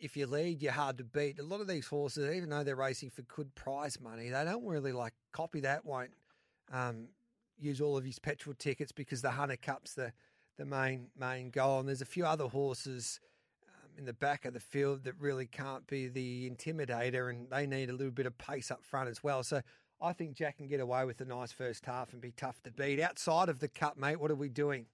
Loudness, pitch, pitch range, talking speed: -38 LUFS, 140 Hz, 130-145 Hz, 240 wpm